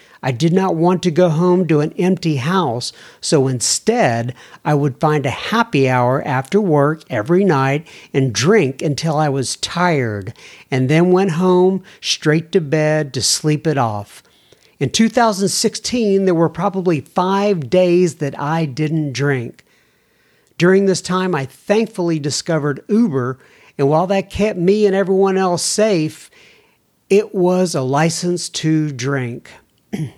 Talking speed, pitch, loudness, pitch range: 145 wpm, 165 Hz, -16 LUFS, 140-190 Hz